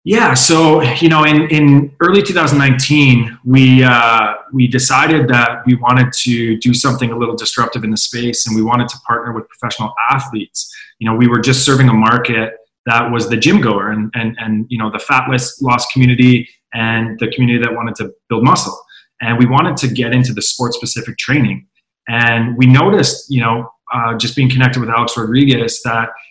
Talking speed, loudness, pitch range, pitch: 195 wpm, -12 LUFS, 115-130 Hz, 120 Hz